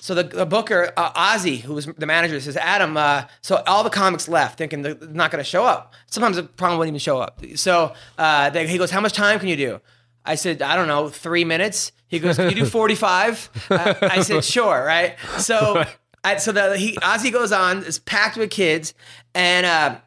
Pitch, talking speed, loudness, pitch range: 175 Hz, 225 wpm, -19 LUFS, 155-195 Hz